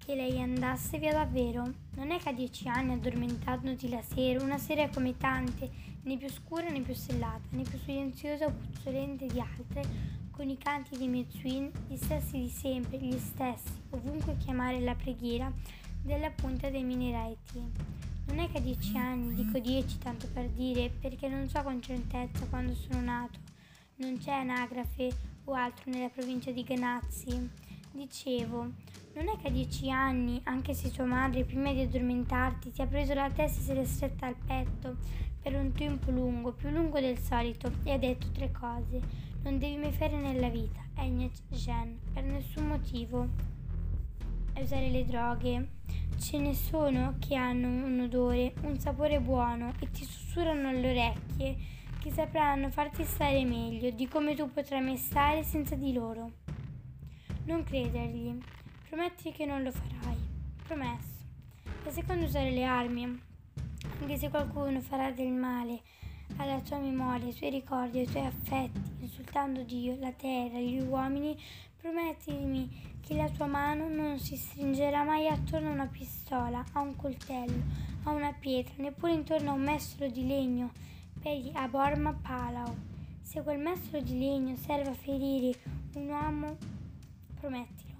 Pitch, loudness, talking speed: 250 Hz, -35 LUFS, 160 wpm